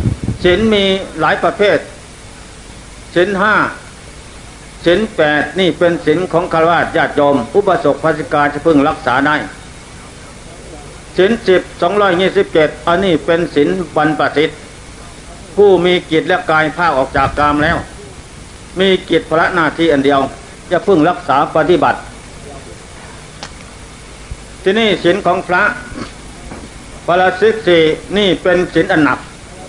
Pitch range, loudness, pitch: 150-180 Hz, -13 LUFS, 165 Hz